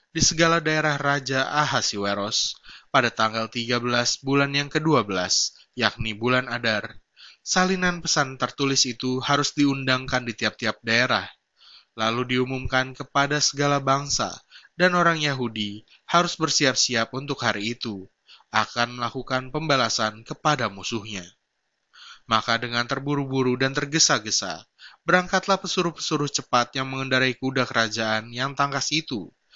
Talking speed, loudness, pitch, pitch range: 115 wpm, -23 LUFS, 130 Hz, 115-145 Hz